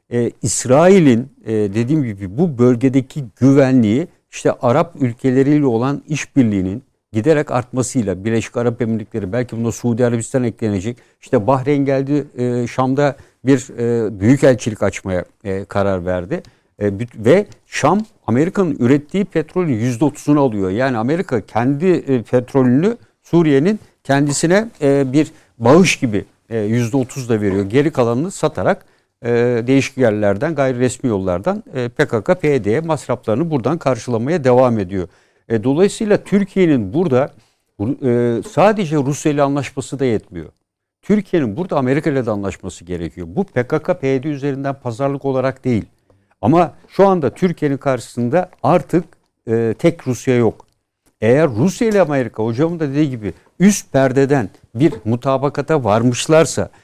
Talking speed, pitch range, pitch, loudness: 125 wpm, 115-150 Hz, 130 Hz, -17 LUFS